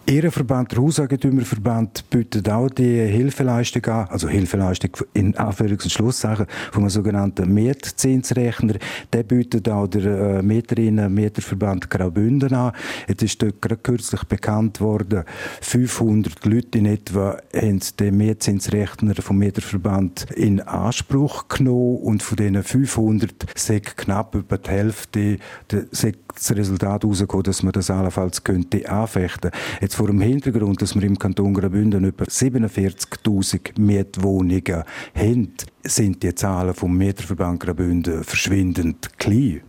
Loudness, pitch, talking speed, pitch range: -20 LUFS, 105 Hz, 125 wpm, 95-115 Hz